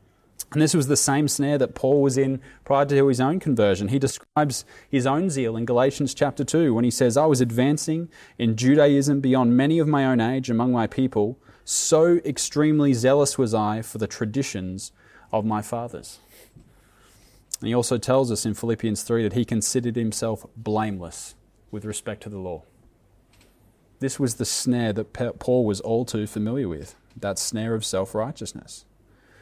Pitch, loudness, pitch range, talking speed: 120 Hz, -23 LUFS, 110-135 Hz, 175 wpm